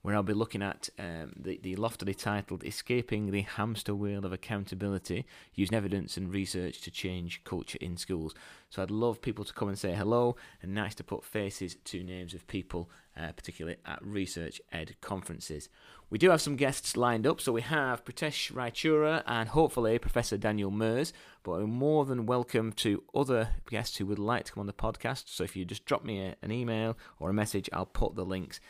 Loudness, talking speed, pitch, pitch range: -33 LUFS, 205 wpm, 100 Hz, 95-115 Hz